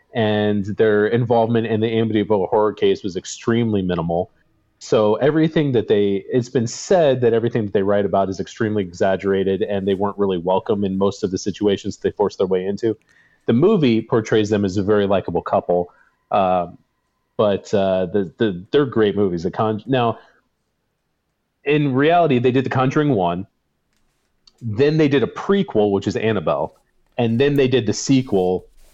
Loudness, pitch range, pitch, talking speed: -19 LUFS, 100-120 Hz, 105 Hz, 170 wpm